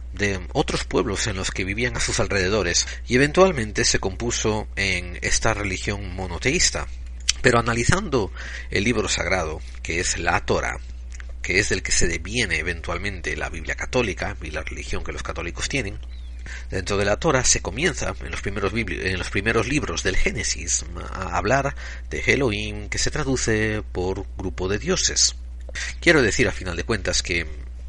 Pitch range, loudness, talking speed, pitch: 65-105 Hz, -23 LUFS, 170 wpm, 90 Hz